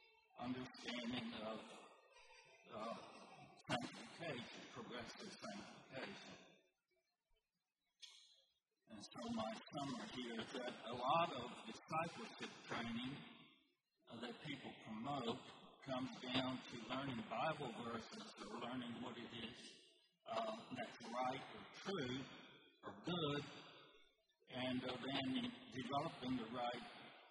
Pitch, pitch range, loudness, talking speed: 130 Hz, 120-145 Hz, -48 LUFS, 100 wpm